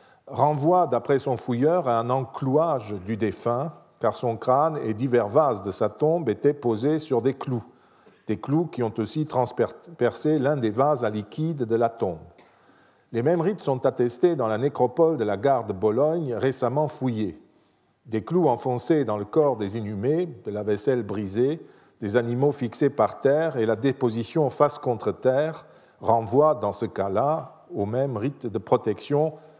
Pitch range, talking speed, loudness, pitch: 115-150 Hz, 170 wpm, -24 LUFS, 125 Hz